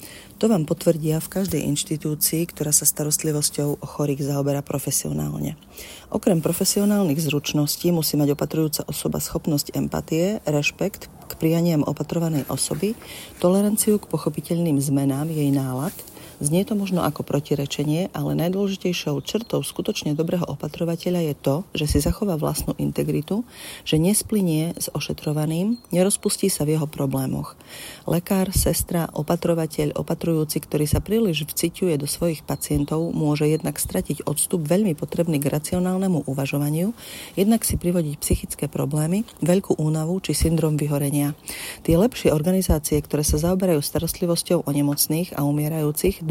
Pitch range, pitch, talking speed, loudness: 145-180 Hz, 155 Hz, 130 wpm, -23 LUFS